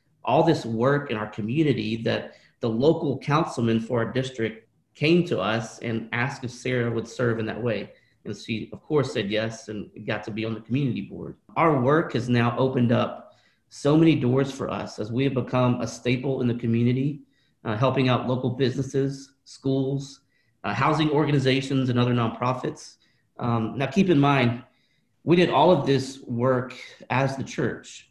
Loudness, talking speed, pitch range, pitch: -24 LUFS, 180 wpm, 115-135 Hz, 125 Hz